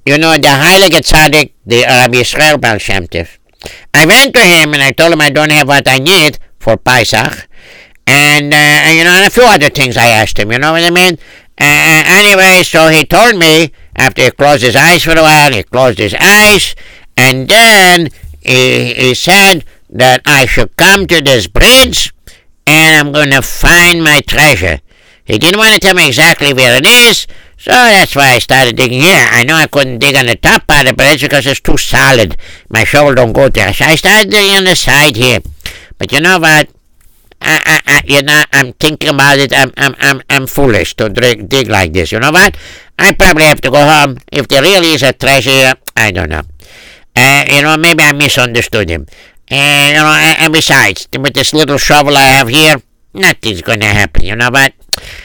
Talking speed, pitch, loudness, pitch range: 210 wpm, 145 Hz, -5 LUFS, 125-160 Hz